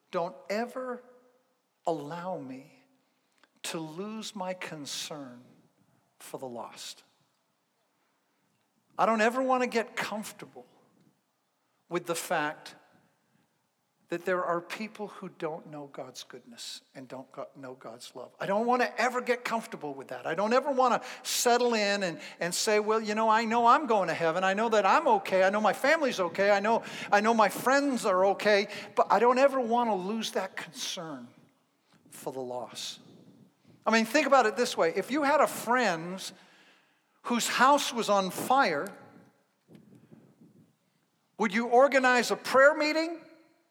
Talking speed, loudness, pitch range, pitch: 155 wpm, -27 LUFS, 185-250 Hz, 215 Hz